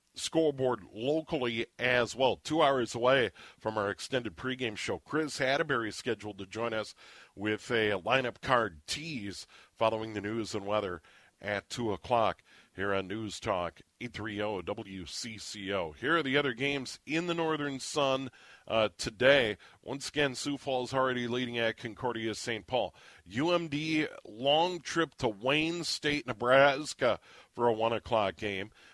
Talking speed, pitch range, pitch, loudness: 145 wpm, 110-140 Hz, 120 Hz, -31 LUFS